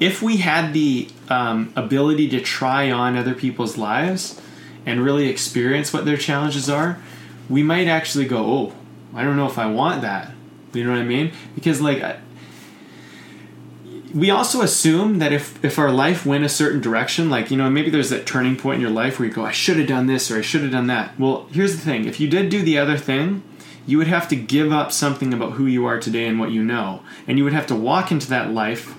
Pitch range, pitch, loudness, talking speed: 120-150 Hz, 135 Hz, -20 LUFS, 230 wpm